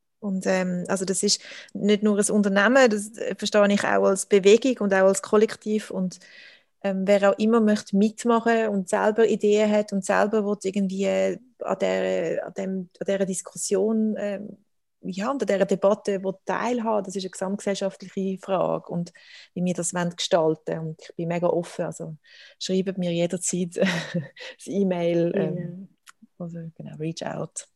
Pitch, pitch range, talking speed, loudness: 195 Hz, 185-210 Hz, 155 wpm, -24 LUFS